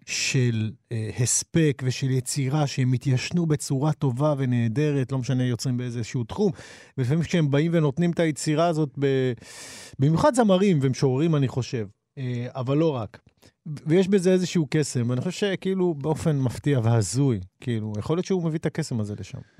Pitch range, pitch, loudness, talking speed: 125-160 Hz, 135 Hz, -24 LUFS, 155 wpm